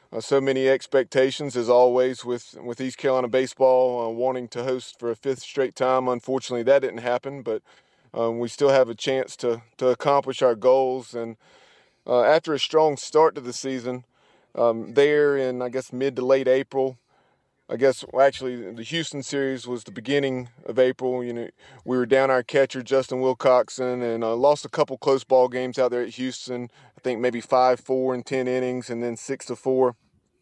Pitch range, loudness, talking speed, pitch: 125-135 Hz, -23 LUFS, 195 wpm, 130 Hz